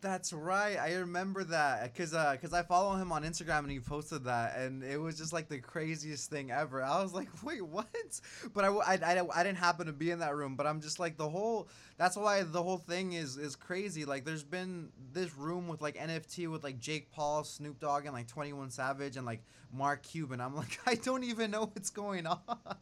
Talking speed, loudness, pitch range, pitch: 230 wpm, -36 LUFS, 145-185 Hz, 160 Hz